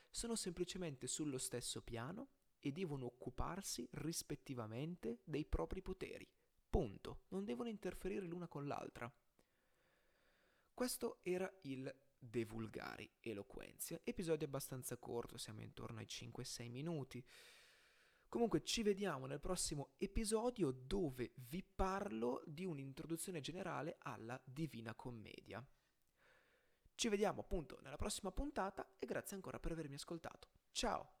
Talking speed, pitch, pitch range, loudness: 115 wpm, 150 Hz, 125-185 Hz, -46 LUFS